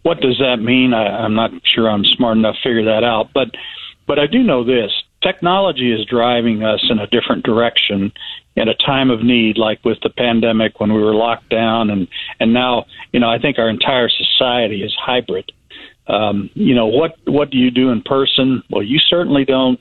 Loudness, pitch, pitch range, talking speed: -15 LUFS, 120 Hz, 110-135 Hz, 210 wpm